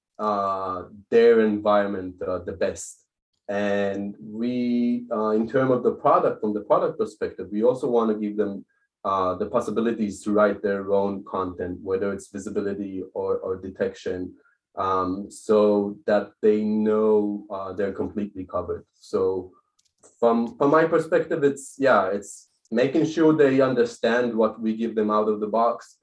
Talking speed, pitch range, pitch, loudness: 155 wpm, 100-120 Hz, 105 Hz, -24 LUFS